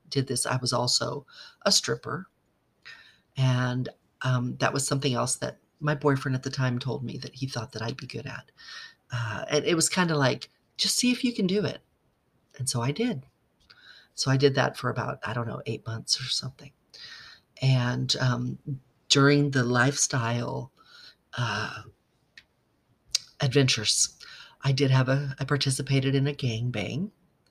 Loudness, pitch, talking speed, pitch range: -27 LUFS, 135 Hz, 170 wpm, 125-145 Hz